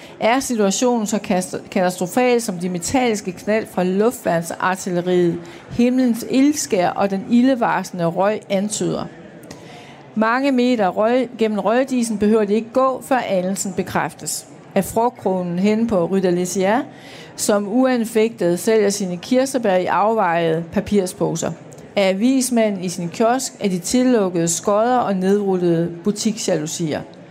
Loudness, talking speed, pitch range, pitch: -19 LUFS, 120 wpm, 180-230 Hz, 205 Hz